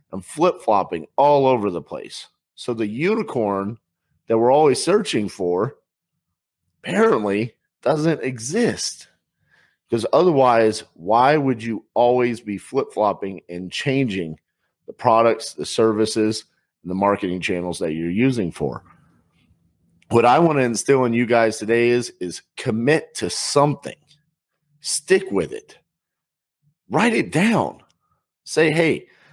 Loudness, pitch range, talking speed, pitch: -20 LUFS, 100-145 Hz, 125 wpm, 120 Hz